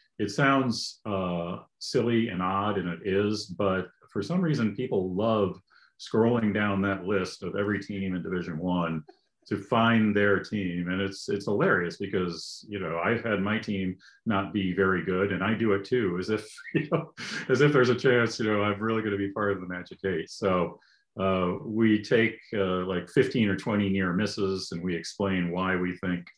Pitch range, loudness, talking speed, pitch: 90-110 Hz, -28 LUFS, 200 wpm, 100 Hz